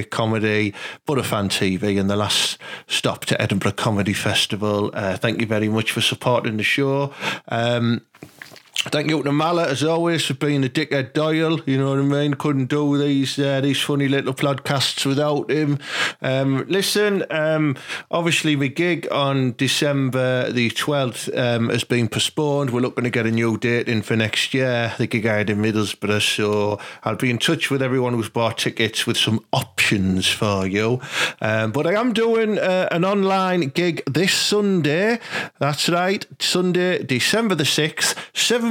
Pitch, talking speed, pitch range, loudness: 135 Hz, 175 wpm, 115-155 Hz, -20 LUFS